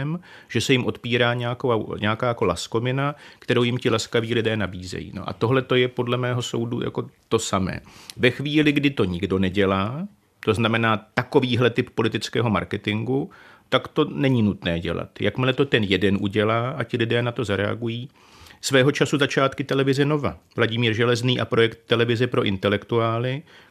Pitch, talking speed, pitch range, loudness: 120 Hz, 165 wpm, 105-130 Hz, -22 LUFS